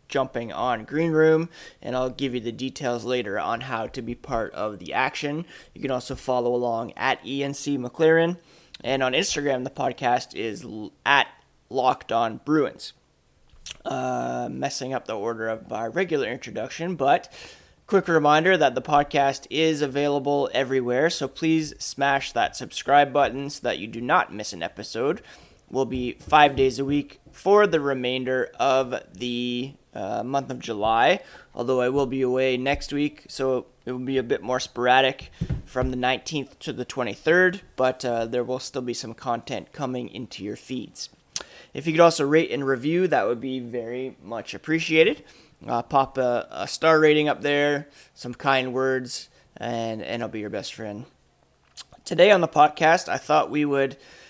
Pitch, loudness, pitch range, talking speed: 130 Hz, -24 LUFS, 125-145 Hz, 170 wpm